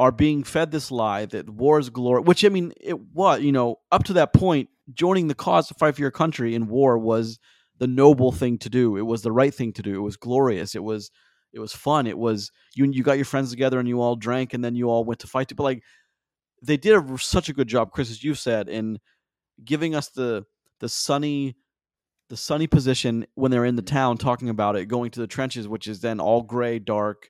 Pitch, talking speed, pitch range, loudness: 125 Hz, 245 wpm, 115-140 Hz, -23 LUFS